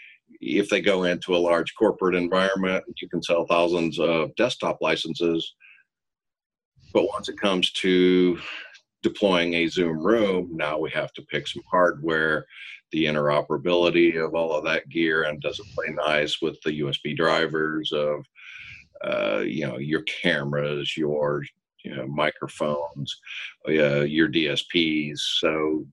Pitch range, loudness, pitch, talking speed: 75-85 Hz, -24 LUFS, 80 Hz, 140 wpm